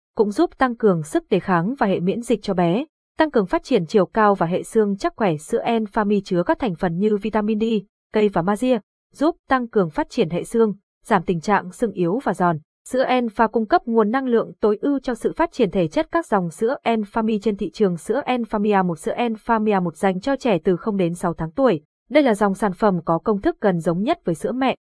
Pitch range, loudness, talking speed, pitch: 190-235 Hz, -21 LUFS, 245 wpm, 215 Hz